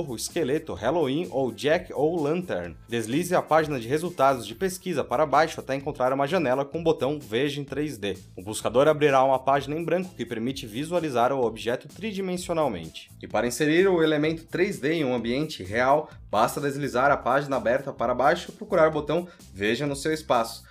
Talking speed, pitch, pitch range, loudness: 185 wpm, 145 Hz, 120-160 Hz, -25 LUFS